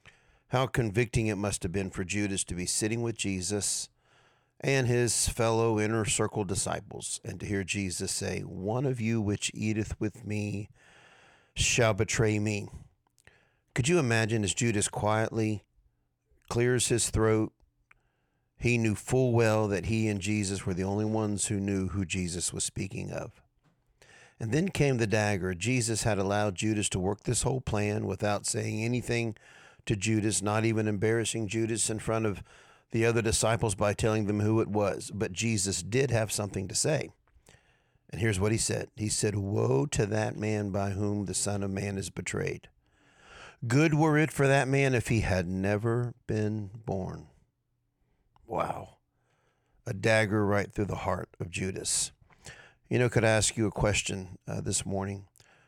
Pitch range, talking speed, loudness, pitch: 100-115 Hz, 165 wpm, -29 LUFS, 110 Hz